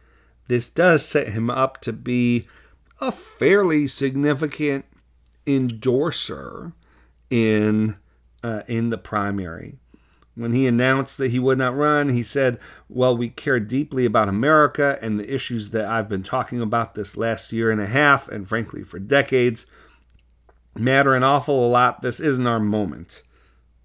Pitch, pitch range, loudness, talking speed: 120 Hz, 105-135 Hz, -21 LUFS, 145 wpm